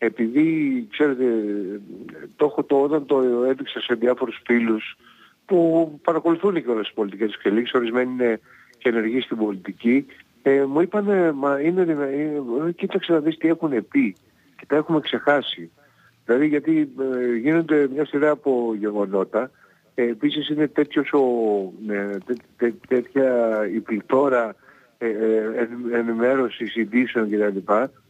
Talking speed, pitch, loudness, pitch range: 145 wpm, 130 Hz, -22 LUFS, 115-150 Hz